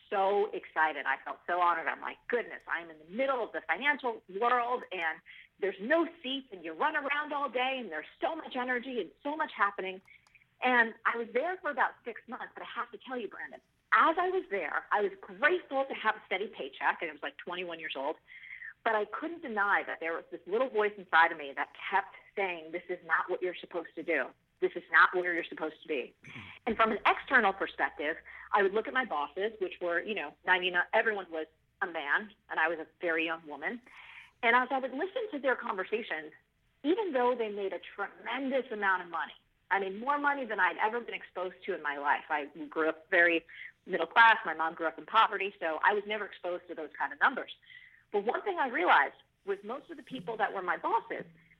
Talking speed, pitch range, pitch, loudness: 230 wpm, 165-260 Hz, 200 Hz, -31 LUFS